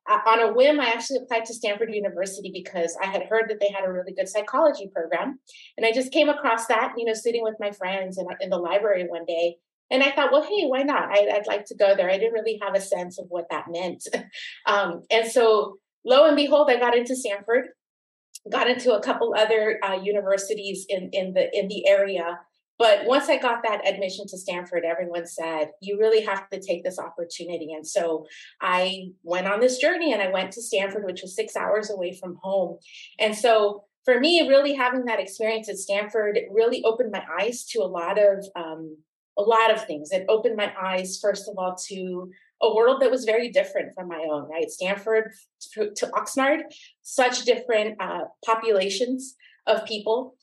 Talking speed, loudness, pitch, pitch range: 205 wpm, -24 LUFS, 210 Hz, 190-245 Hz